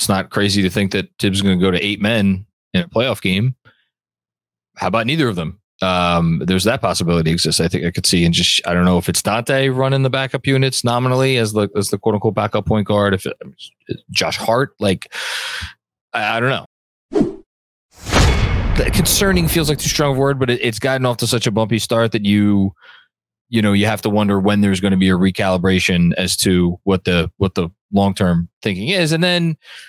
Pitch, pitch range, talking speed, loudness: 100 Hz, 90-120 Hz, 215 wpm, -17 LUFS